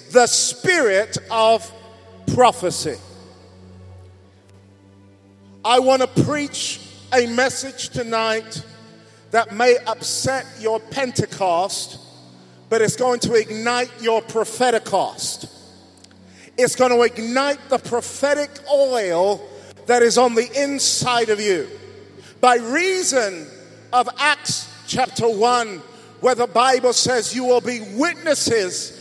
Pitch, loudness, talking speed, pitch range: 235 Hz, -19 LUFS, 110 wpm, 170-255 Hz